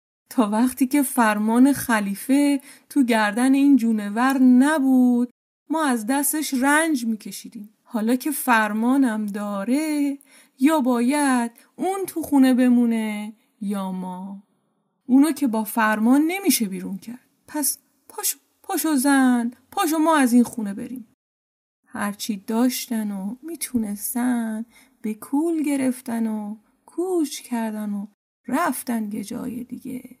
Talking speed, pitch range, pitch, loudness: 115 wpm, 220-280 Hz, 250 Hz, -21 LUFS